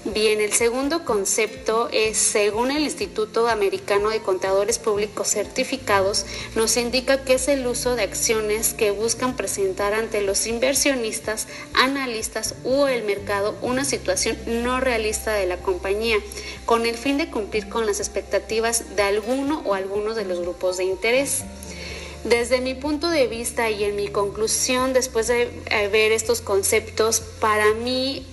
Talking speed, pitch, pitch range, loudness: 150 wpm, 225 Hz, 205-255 Hz, -22 LUFS